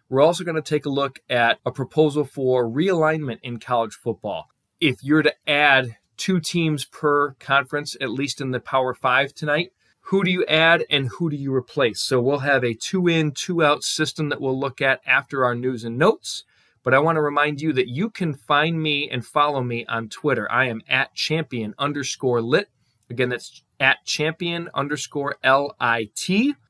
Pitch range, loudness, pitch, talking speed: 125-155 Hz, -21 LUFS, 140 Hz, 190 wpm